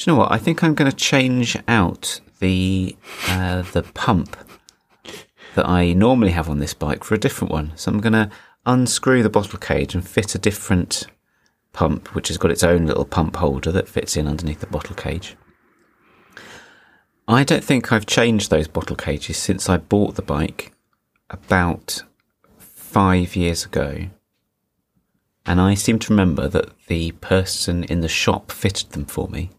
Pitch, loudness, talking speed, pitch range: 95 Hz, -19 LUFS, 175 wpm, 85-110 Hz